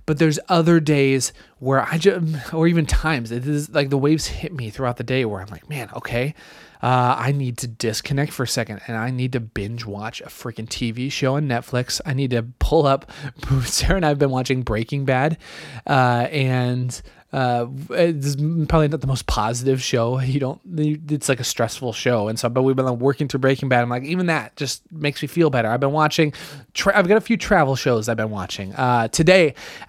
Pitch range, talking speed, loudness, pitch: 120-150 Hz, 215 wpm, -21 LUFS, 135 Hz